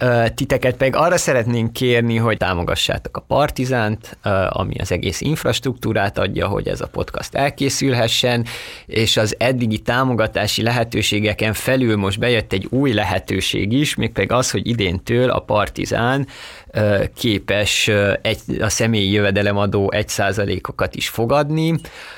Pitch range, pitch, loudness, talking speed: 100-125 Hz, 115 Hz, -18 LUFS, 125 wpm